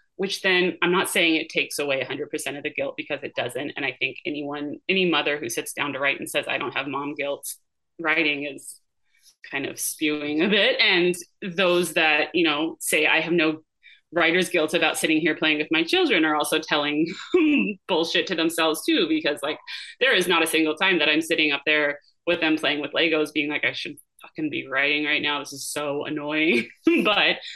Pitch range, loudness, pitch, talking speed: 150-180 Hz, -22 LUFS, 160 Hz, 210 wpm